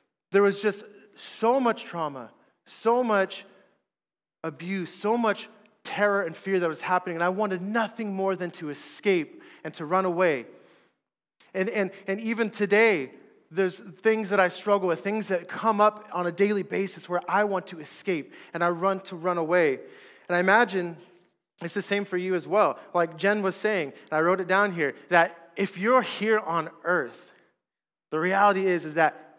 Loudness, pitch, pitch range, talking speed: -26 LUFS, 195 Hz, 175-210 Hz, 185 wpm